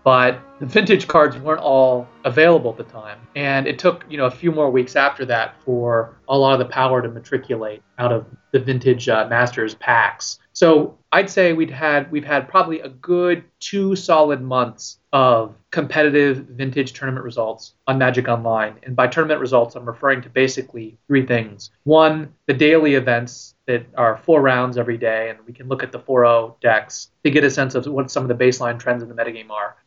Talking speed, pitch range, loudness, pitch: 200 wpm, 115-145 Hz, -18 LUFS, 130 Hz